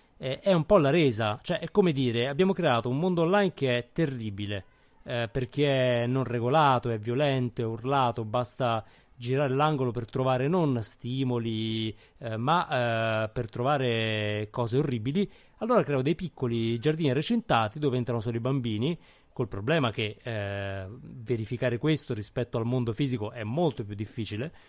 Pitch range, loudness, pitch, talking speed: 115-145 Hz, -28 LUFS, 125 Hz, 160 wpm